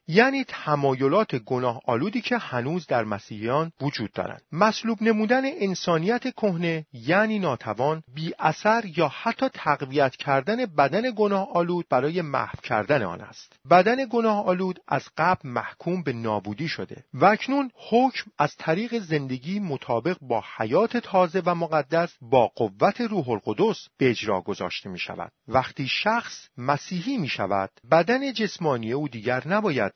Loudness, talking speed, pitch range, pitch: -25 LUFS, 140 wpm, 135-210 Hz, 170 Hz